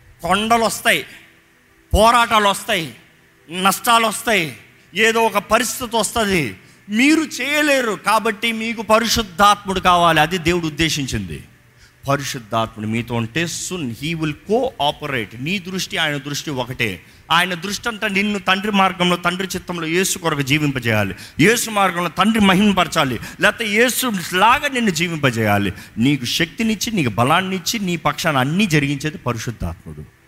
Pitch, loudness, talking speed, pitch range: 180 Hz, -18 LUFS, 120 wpm, 140-215 Hz